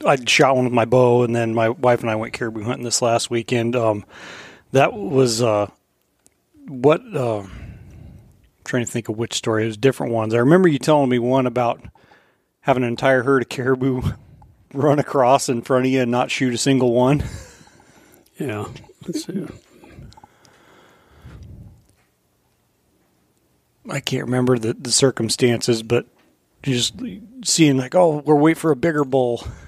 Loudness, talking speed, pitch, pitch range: -19 LUFS, 160 wpm, 125 Hz, 115-135 Hz